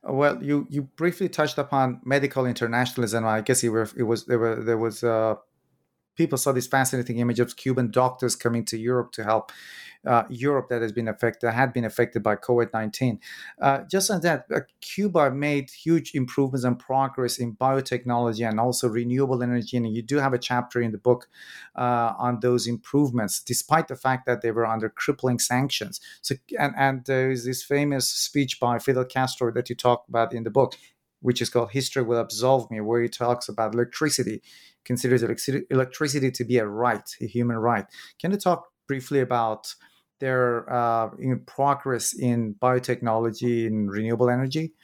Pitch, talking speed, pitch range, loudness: 125 Hz, 180 wpm, 115-135 Hz, -25 LUFS